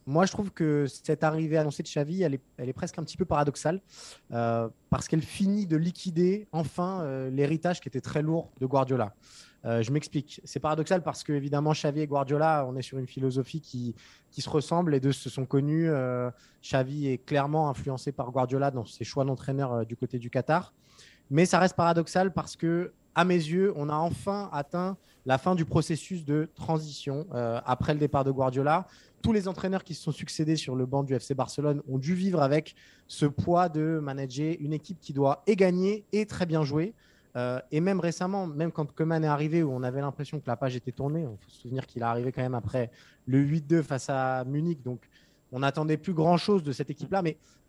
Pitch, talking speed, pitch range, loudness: 150 Hz, 215 wpm, 135-165 Hz, -29 LUFS